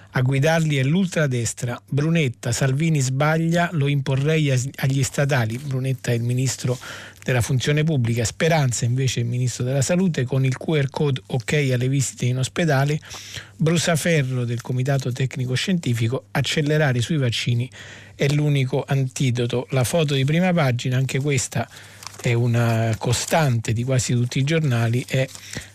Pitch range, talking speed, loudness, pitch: 120-145 Hz, 145 wpm, -21 LUFS, 130 Hz